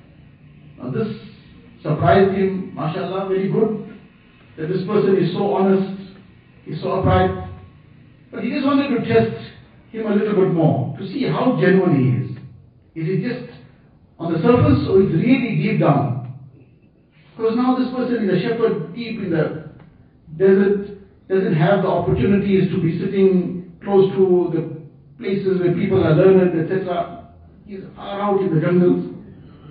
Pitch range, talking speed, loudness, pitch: 155-200 Hz, 155 wpm, -18 LUFS, 185 Hz